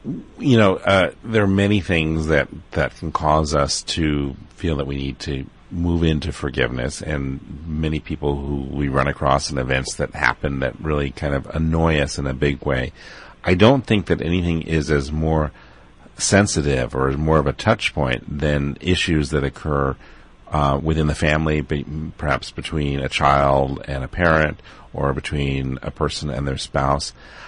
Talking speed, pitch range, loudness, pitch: 180 wpm, 70-80 Hz, -20 LUFS, 75 Hz